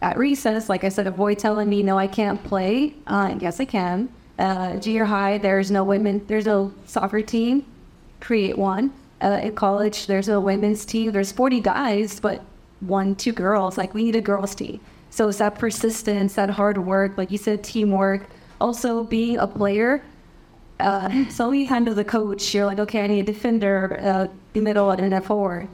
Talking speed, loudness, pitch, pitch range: 195 wpm, -22 LUFS, 205 Hz, 195-225 Hz